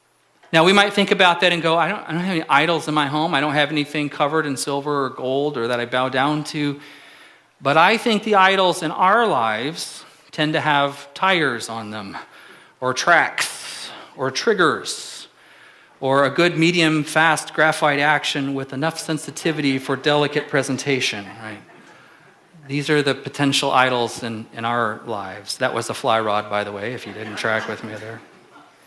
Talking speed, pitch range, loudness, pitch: 185 wpm, 125-160 Hz, -19 LUFS, 145 Hz